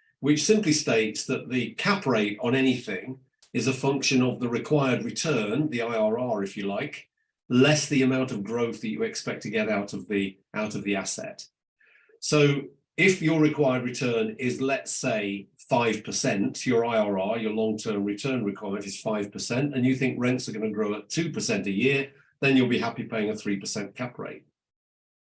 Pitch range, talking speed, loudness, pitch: 105-140 Hz, 180 wpm, -26 LUFS, 125 Hz